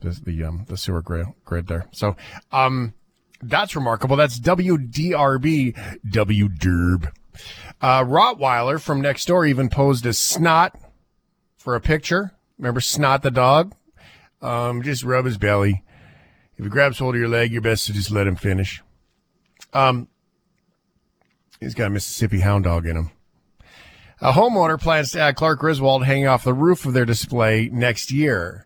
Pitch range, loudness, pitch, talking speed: 100-145 Hz, -20 LUFS, 125 Hz, 155 wpm